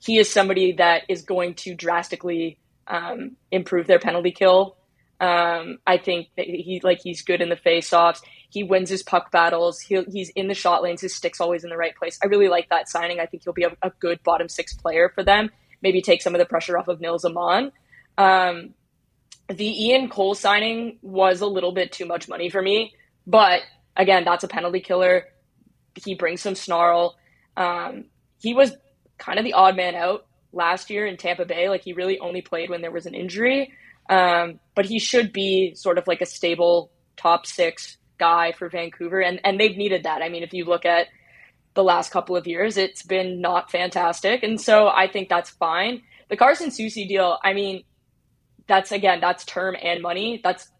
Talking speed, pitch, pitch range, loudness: 200 wpm, 180 Hz, 170-195 Hz, -21 LUFS